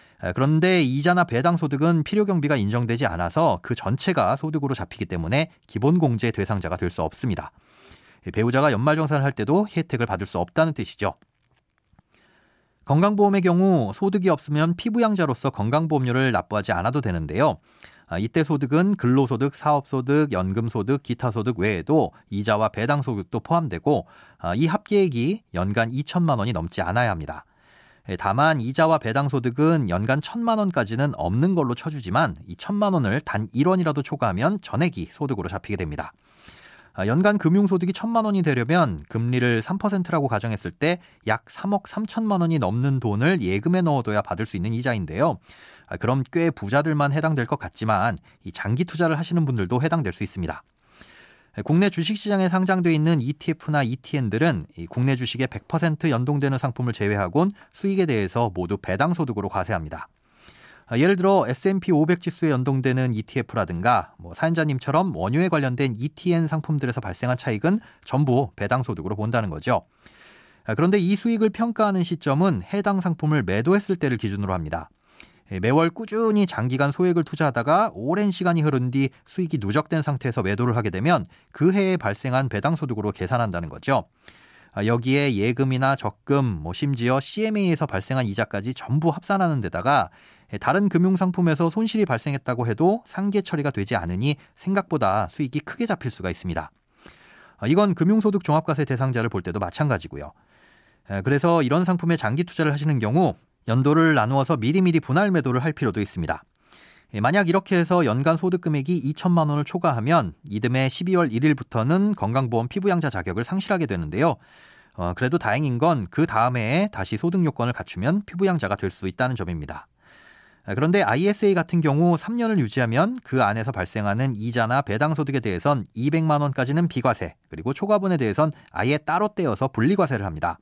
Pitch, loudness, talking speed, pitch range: 140 Hz, -23 LUFS, 370 characters per minute, 115-170 Hz